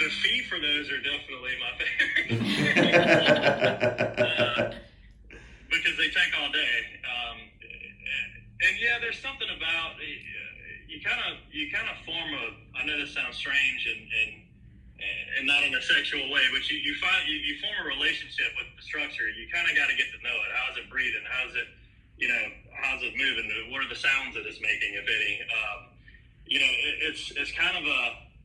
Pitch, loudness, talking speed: 225 Hz, -26 LUFS, 200 wpm